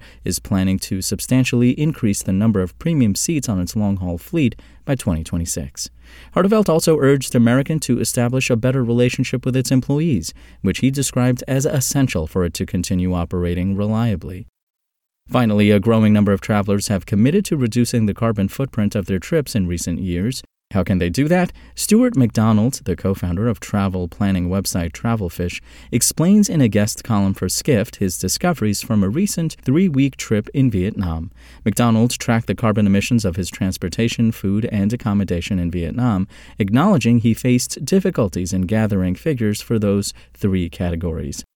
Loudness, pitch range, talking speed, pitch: -19 LUFS, 95-125 Hz, 165 wpm, 105 Hz